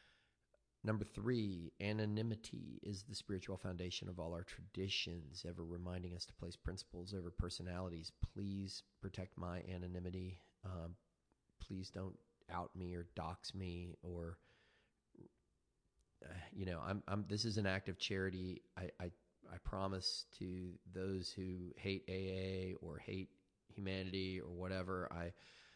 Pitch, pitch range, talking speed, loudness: 95 Hz, 90-95 Hz, 135 wpm, -46 LUFS